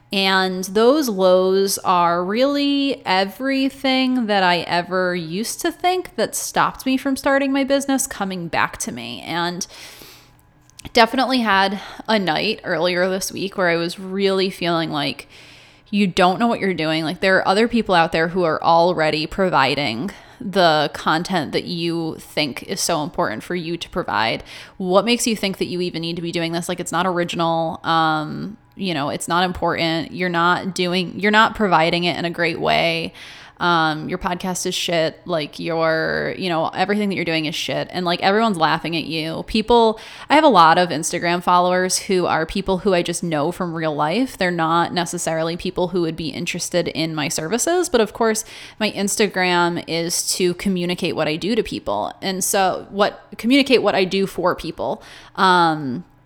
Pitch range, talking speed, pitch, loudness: 165-200 Hz, 185 wpm, 180 Hz, -19 LUFS